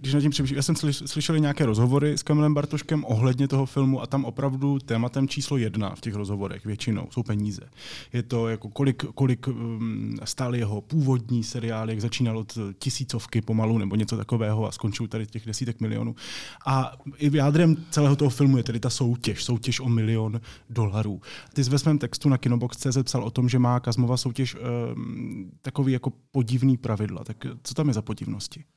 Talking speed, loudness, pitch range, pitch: 185 wpm, -26 LUFS, 115-140 Hz, 125 Hz